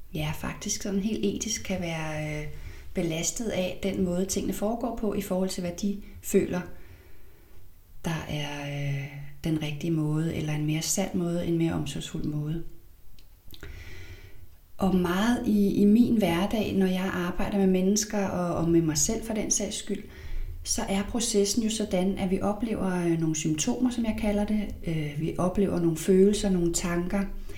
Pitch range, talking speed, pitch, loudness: 155-200 Hz, 165 wpm, 180 Hz, -27 LUFS